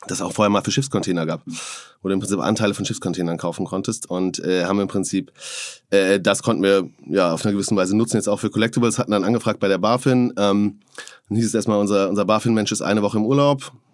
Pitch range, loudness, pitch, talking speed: 95-110 Hz, -20 LUFS, 105 Hz, 240 wpm